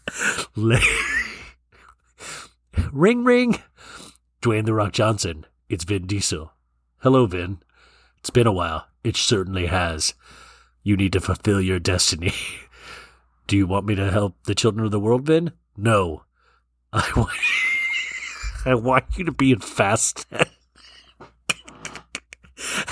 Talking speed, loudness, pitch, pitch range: 120 wpm, -21 LUFS, 100 Hz, 85-120 Hz